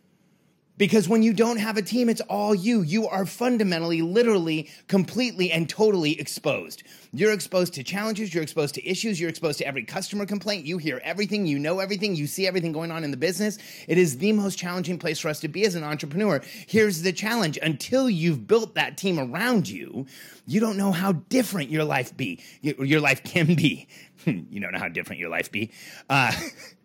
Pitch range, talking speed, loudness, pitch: 160-210 Hz, 220 wpm, -25 LUFS, 185 Hz